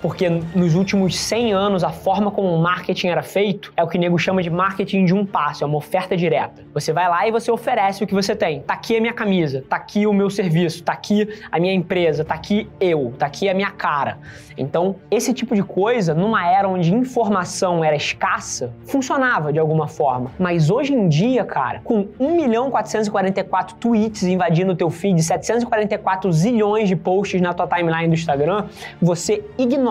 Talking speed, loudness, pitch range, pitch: 200 wpm, -19 LUFS, 170-210 Hz, 190 Hz